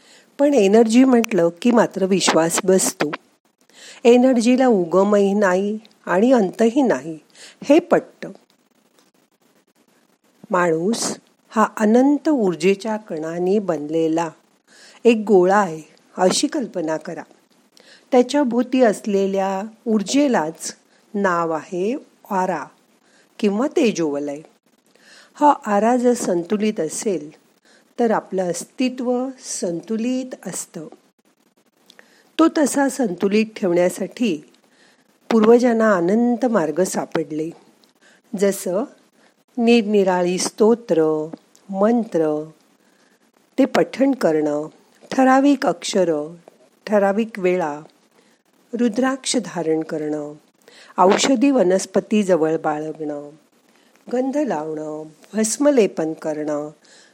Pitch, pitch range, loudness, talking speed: 210 Hz, 170-250 Hz, -19 LUFS, 80 wpm